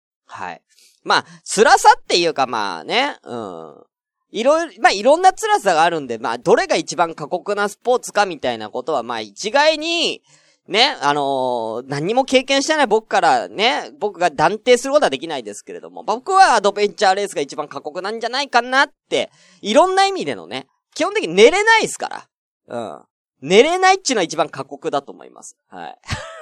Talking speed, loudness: 380 characters per minute, -17 LUFS